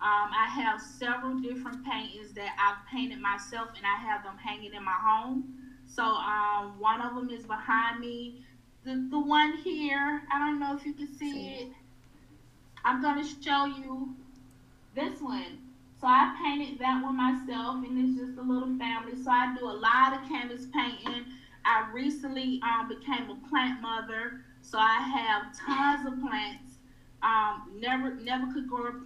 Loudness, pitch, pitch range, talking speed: -30 LUFS, 255 Hz, 220-270 Hz, 170 wpm